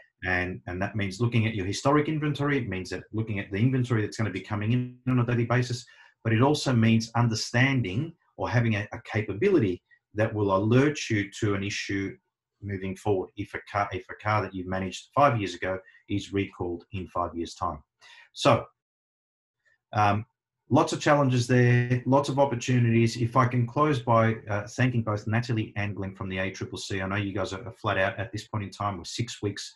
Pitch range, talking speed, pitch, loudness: 100-125 Hz, 205 wpm, 110 Hz, -27 LUFS